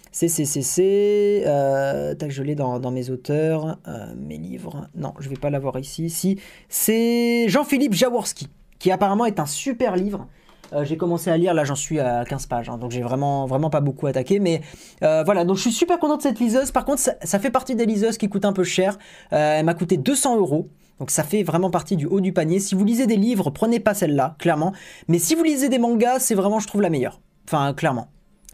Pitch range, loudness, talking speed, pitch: 150-220 Hz, -21 LUFS, 225 wpm, 180 Hz